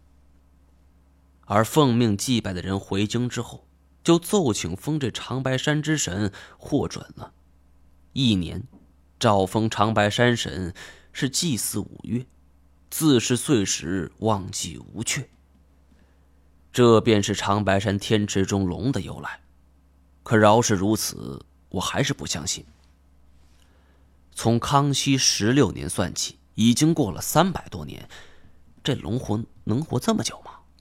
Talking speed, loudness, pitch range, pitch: 185 characters per minute, -23 LUFS, 70-115 Hz, 95 Hz